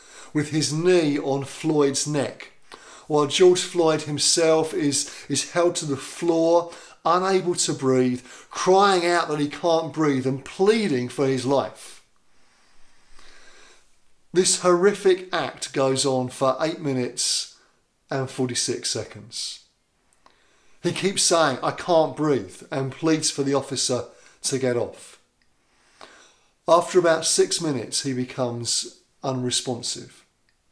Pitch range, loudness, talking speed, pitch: 135-170 Hz, -22 LUFS, 120 wpm, 150 Hz